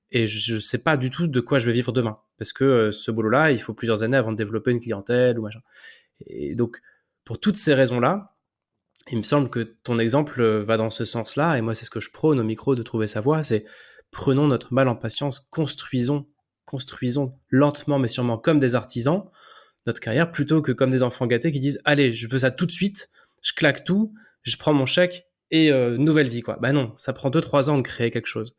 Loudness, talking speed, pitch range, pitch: -22 LUFS, 235 wpm, 115-145 Hz, 130 Hz